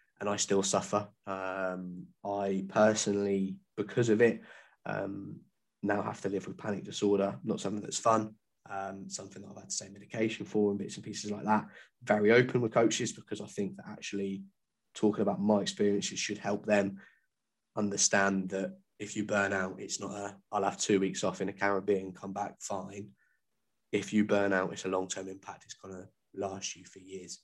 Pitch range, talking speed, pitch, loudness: 95-105 Hz, 190 wpm, 100 Hz, -32 LUFS